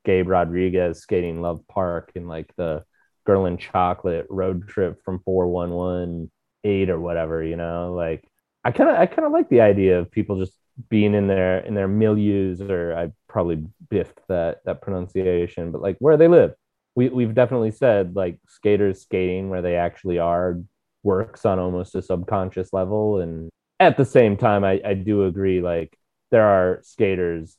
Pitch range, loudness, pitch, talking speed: 85-100 Hz, -21 LUFS, 95 Hz, 175 wpm